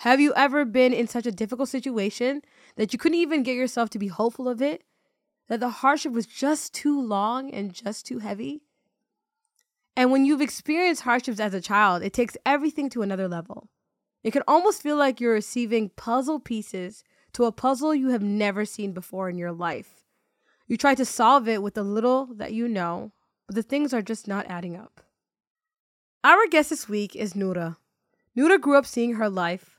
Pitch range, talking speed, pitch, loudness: 210-280 Hz, 195 wpm, 240 Hz, -24 LUFS